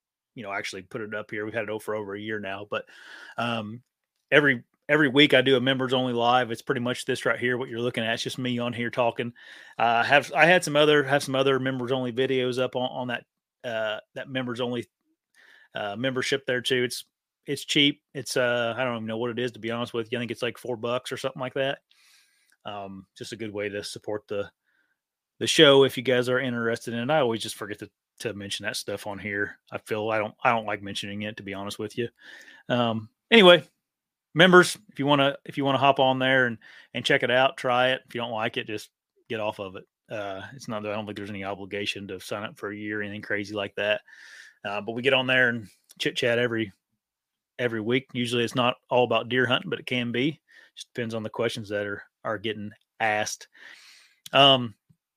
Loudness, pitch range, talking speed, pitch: -25 LUFS, 110-130 Hz, 240 wpm, 120 Hz